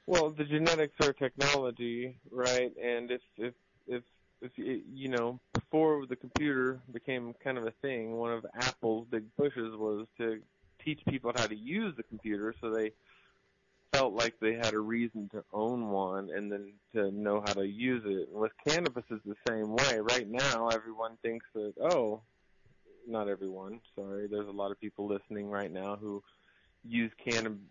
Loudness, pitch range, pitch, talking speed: -34 LUFS, 105-125 Hz, 115 Hz, 175 wpm